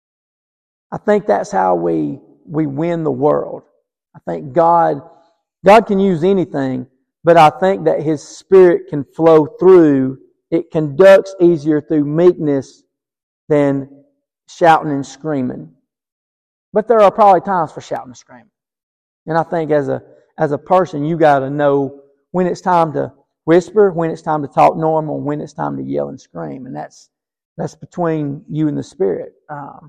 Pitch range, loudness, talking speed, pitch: 140-175 Hz, -14 LUFS, 165 wpm, 155 Hz